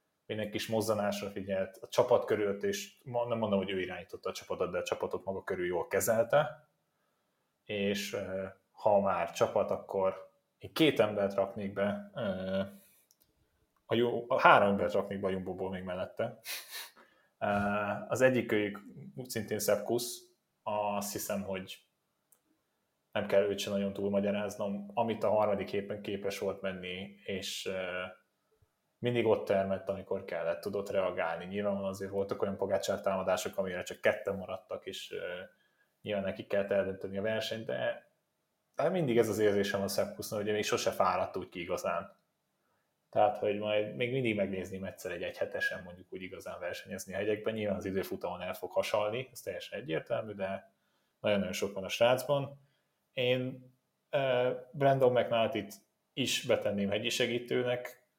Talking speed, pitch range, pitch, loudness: 155 wpm, 100-125 Hz, 105 Hz, -33 LUFS